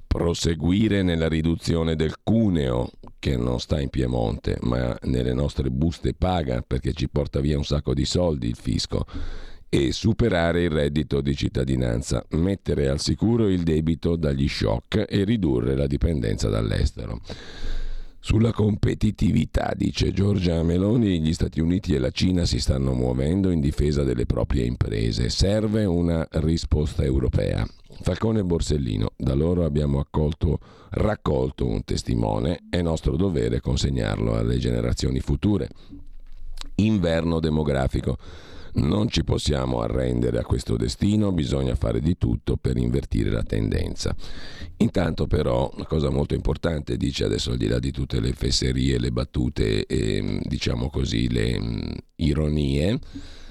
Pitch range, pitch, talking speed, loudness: 65-90 Hz, 80 Hz, 135 wpm, -24 LUFS